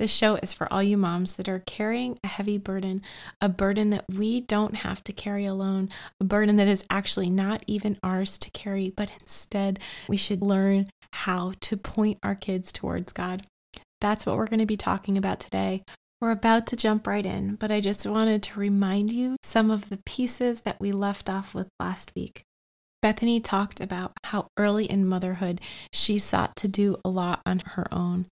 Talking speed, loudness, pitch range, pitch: 195 wpm, -26 LUFS, 190-215 Hz, 200 Hz